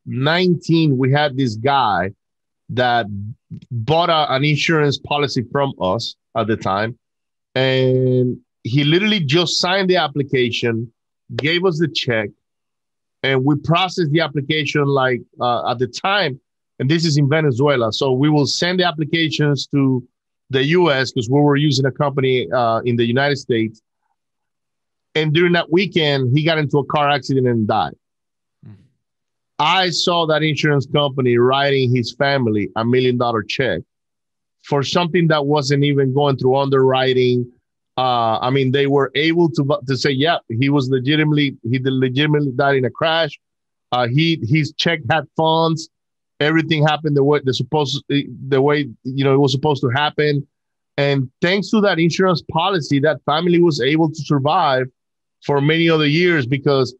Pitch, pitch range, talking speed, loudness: 140 Hz, 130-155 Hz, 160 wpm, -17 LUFS